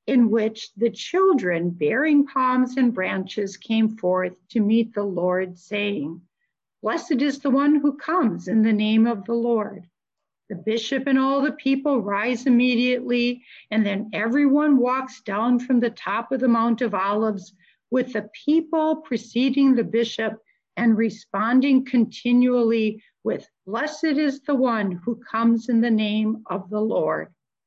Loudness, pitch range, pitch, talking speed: -22 LUFS, 215-260 Hz, 230 Hz, 150 wpm